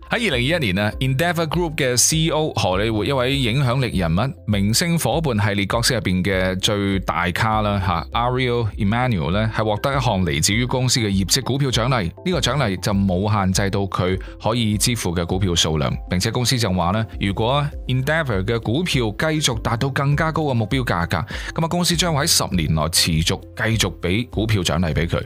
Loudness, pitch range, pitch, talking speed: -20 LUFS, 95-130 Hz, 110 Hz, 365 characters per minute